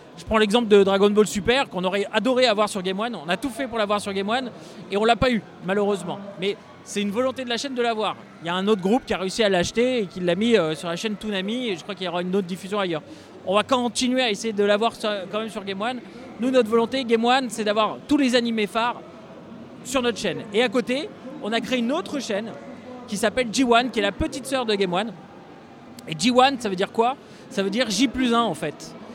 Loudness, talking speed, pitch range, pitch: -23 LUFS, 270 wpm, 200-250 Hz, 220 Hz